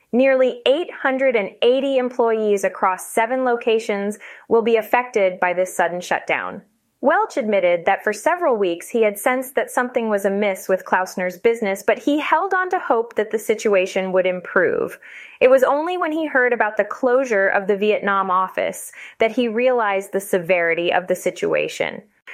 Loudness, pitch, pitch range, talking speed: -19 LUFS, 225 Hz, 195-265 Hz, 165 wpm